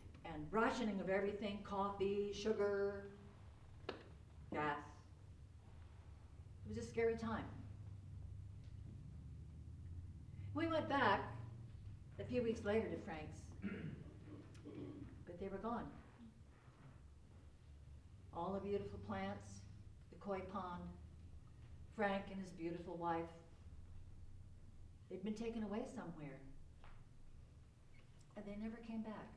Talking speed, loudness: 95 wpm, -45 LUFS